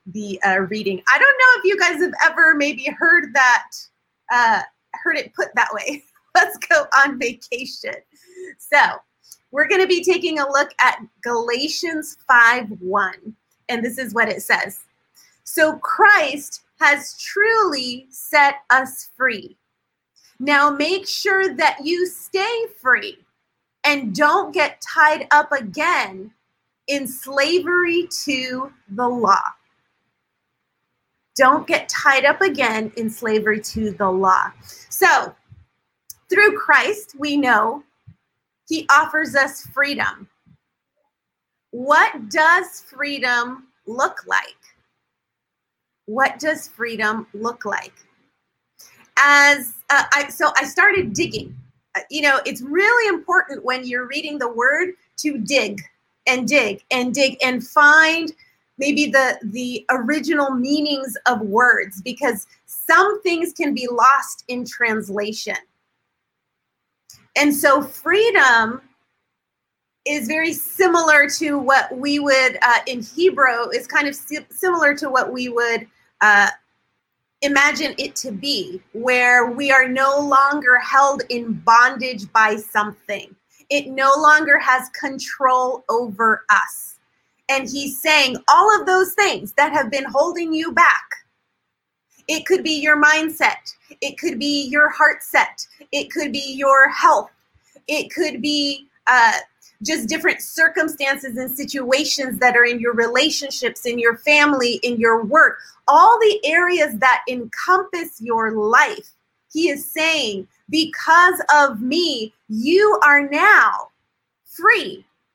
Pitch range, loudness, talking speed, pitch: 245-315 Hz, -17 LUFS, 125 wpm, 280 Hz